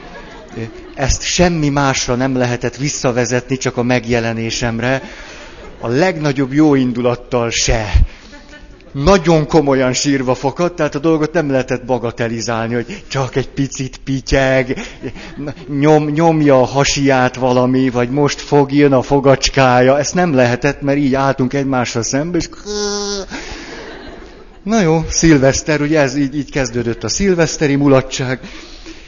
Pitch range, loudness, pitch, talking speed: 125-150 Hz, -15 LUFS, 135 Hz, 120 wpm